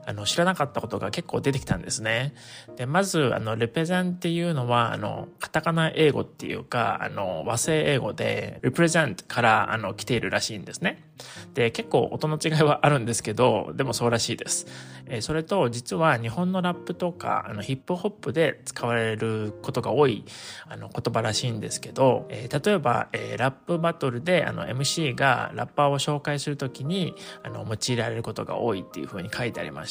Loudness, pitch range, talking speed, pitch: -26 LUFS, 115-160 Hz, 390 characters per minute, 135 Hz